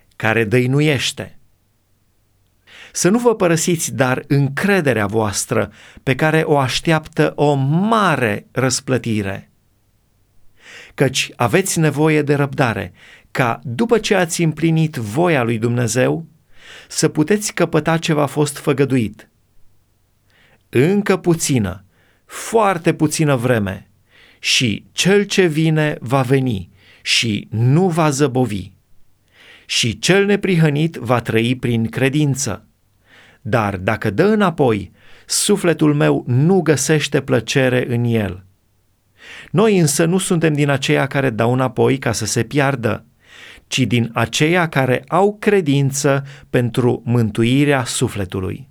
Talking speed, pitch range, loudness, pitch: 110 wpm, 110-155 Hz, -17 LUFS, 130 Hz